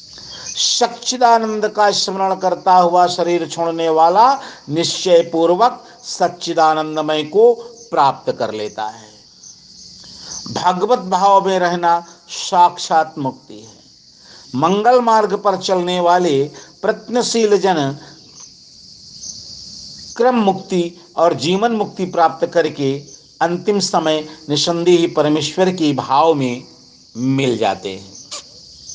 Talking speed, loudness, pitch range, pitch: 95 wpm, -16 LUFS, 155-200 Hz, 175 Hz